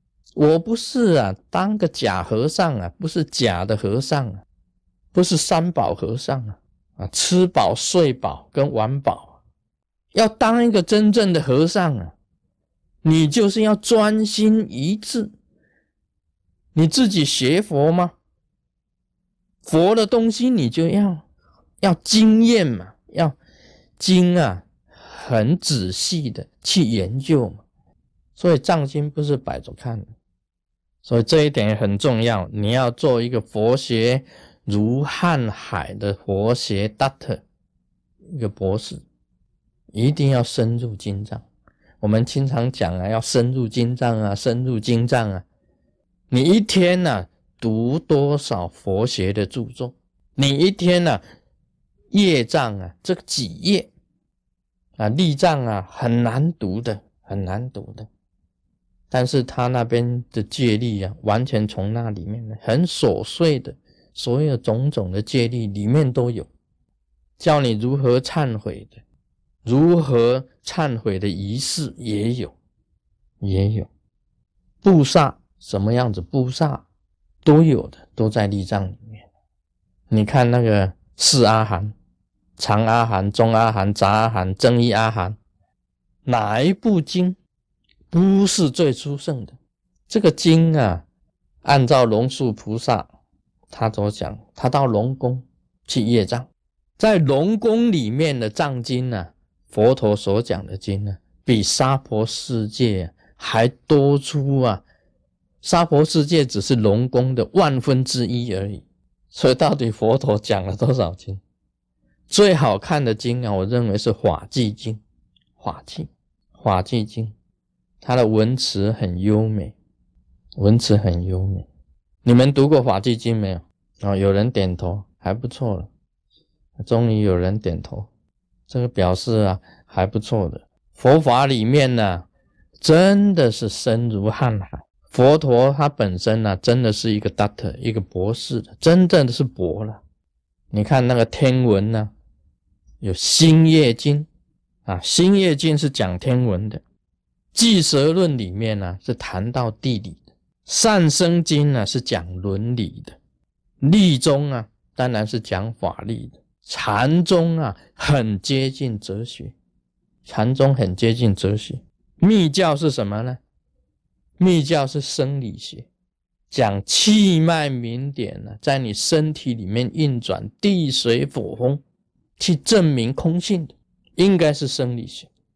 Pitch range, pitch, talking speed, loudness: 100-145 Hz, 120 Hz, 195 characters per minute, -19 LUFS